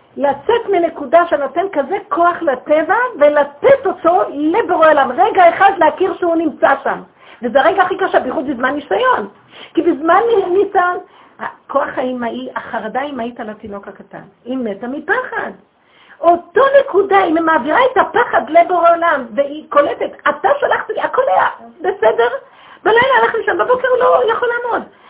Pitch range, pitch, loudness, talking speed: 280-395 Hz, 335 Hz, -14 LUFS, 145 wpm